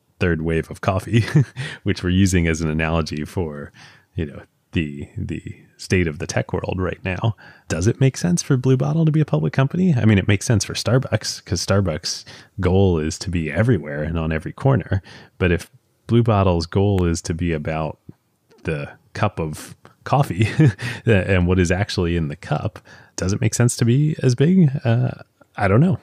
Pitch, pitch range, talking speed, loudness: 100 Hz, 85-130 Hz, 195 wpm, -20 LUFS